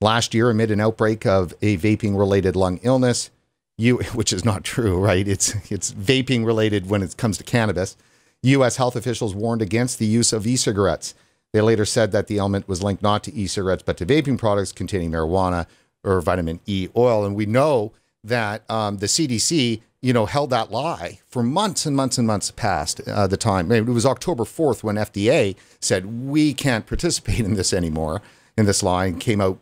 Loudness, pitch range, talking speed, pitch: -21 LUFS, 100-120 Hz, 195 wpm, 110 Hz